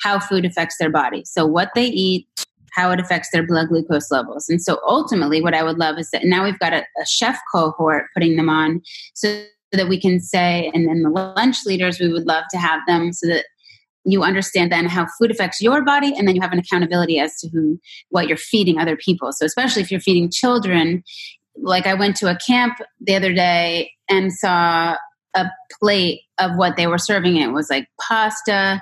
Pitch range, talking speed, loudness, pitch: 165-195 Hz, 215 wpm, -18 LUFS, 180 Hz